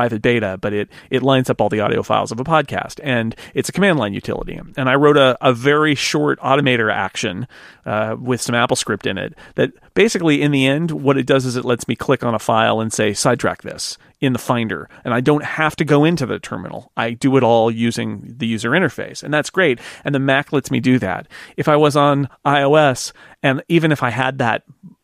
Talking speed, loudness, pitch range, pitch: 230 wpm, -17 LUFS, 115-145 Hz, 130 Hz